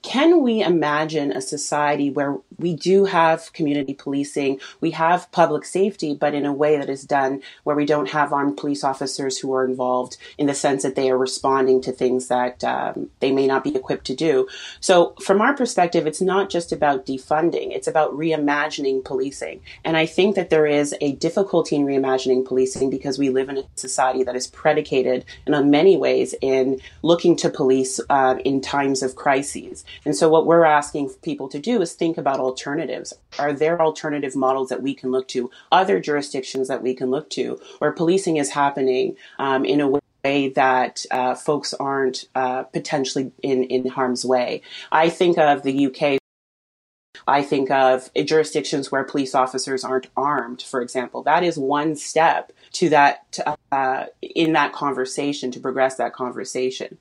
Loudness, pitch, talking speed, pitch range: -21 LUFS, 140 Hz, 180 wpm, 130-155 Hz